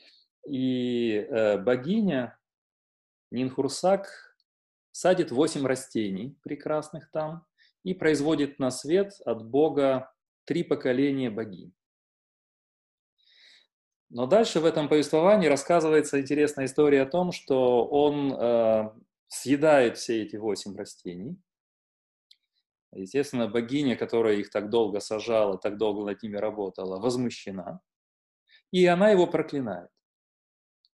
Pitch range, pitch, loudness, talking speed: 115-160 Hz, 135 Hz, -26 LUFS, 100 wpm